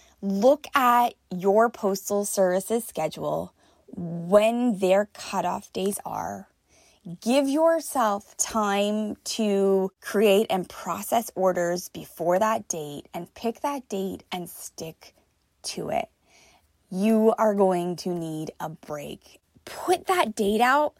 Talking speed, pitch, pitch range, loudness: 115 wpm, 205 Hz, 185-230 Hz, -25 LUFS